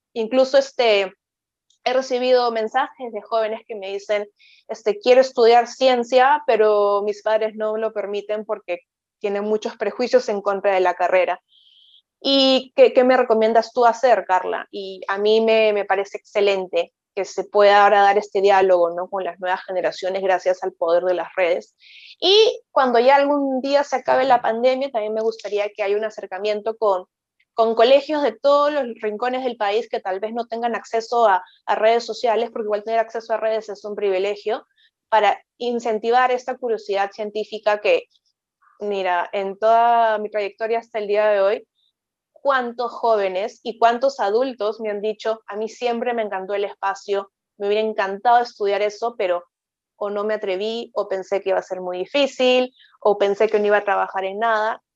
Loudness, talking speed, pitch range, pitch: -20 LUFS, 180 wpm, 200-240 Hz, 215 Hz